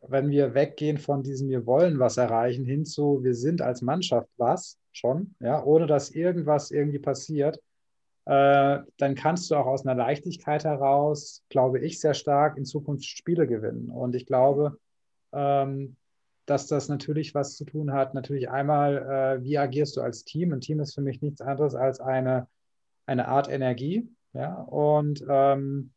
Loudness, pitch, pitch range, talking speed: -26 LUFS, 140 Hz, 130-150 Hz, 170 wpm